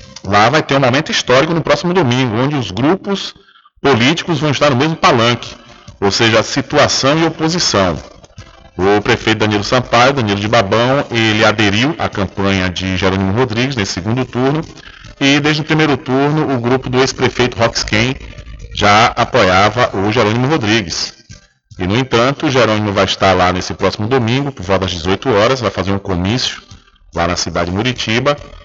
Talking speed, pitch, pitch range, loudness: 170 wpm, 115 Hz, 100-135 Hz, -13 LUFS